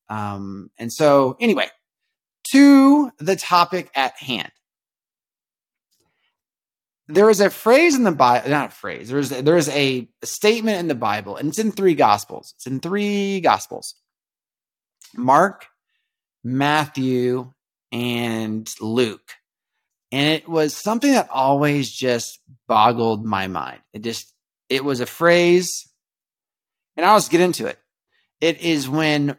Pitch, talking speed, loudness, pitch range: 145 Hz, 135 wpm, -18 LUFS, 125-185 Hz